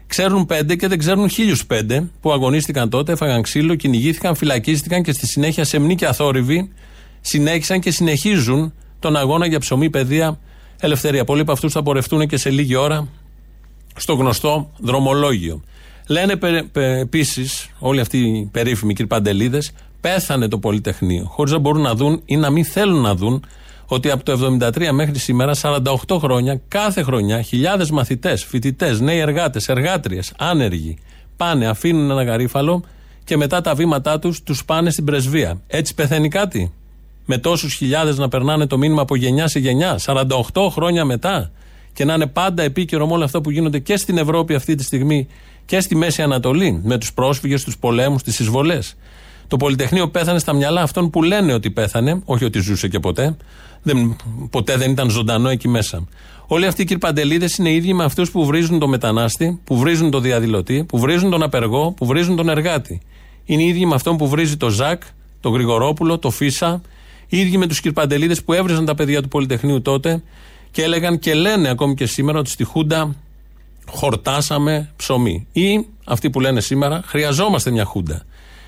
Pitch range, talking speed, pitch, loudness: 125-165 Hz, 170 wpm, 145 Hz, -17 LUFS